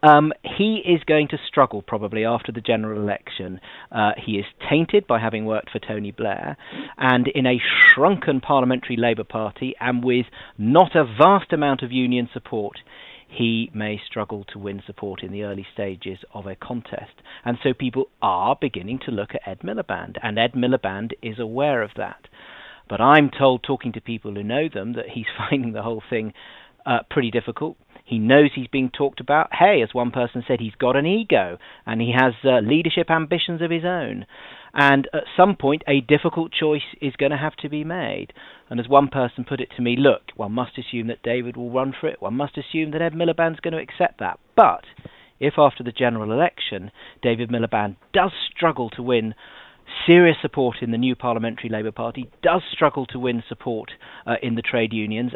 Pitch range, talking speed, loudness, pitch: 115-145 Hz, 195 wpm, -21 LUFS, 125 Hz